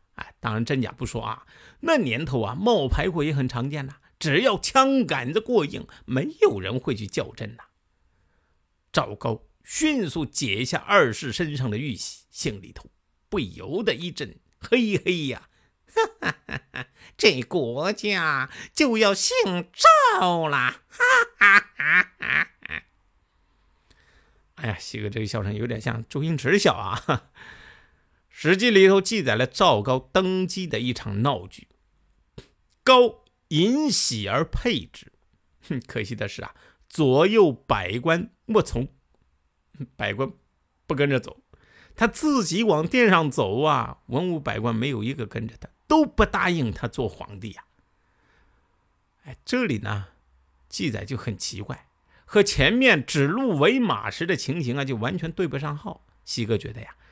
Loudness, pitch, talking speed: -23 LUFS, 140 Hz, 205 characters per minute